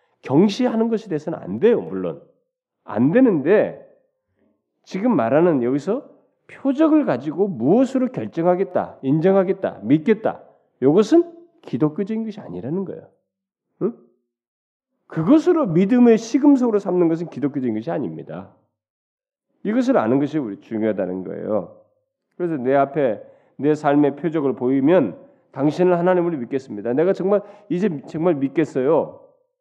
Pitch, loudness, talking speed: 190 Hz, -20 LUFS, 305 characters per minute